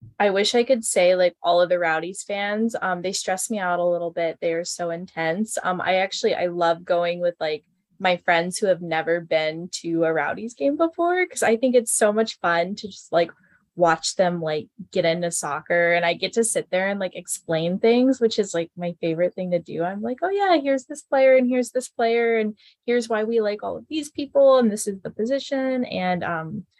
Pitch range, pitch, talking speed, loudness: 170-230 Hz, 185 Hz, 230 wpm, -22 LUFS